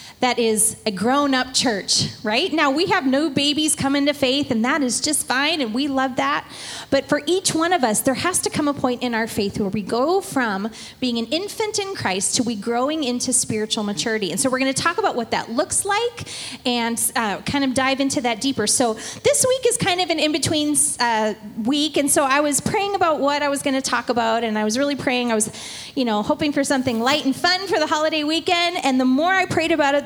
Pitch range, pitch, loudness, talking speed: 240-310 Hz, 275 Hz, -20 LUFS, 240 wpm